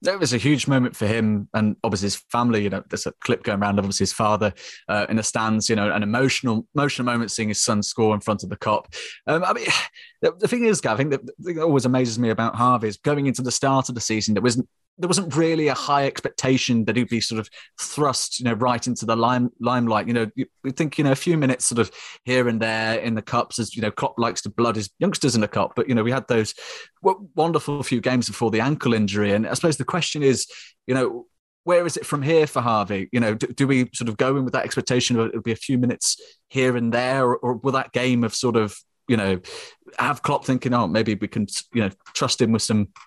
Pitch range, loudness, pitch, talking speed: 110-135 Hz, -22 LUFS, 120 Hz, 260 wpm